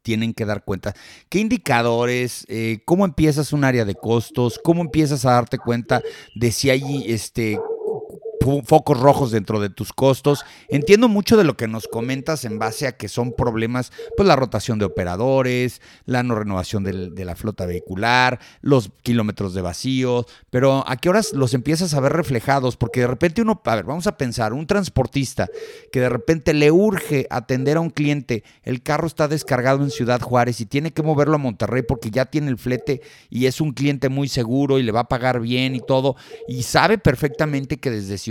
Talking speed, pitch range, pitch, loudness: 195 wpm, 120-150 Hz, 130 Hz, -20 LUFS